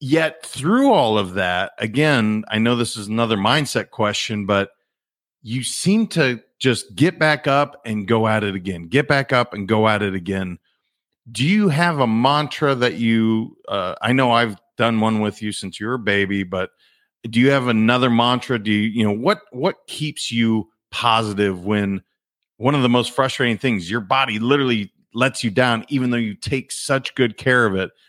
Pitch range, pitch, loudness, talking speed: 105-135 Hz, 115 Hz, -19 LUFS, 195 wpm